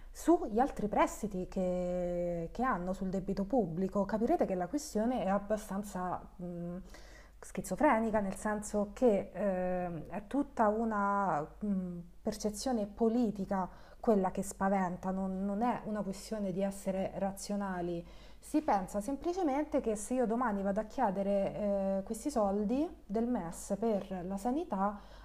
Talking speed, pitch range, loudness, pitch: 135 wpm, 190-230 Hz, -34 LUFS, 200 Hz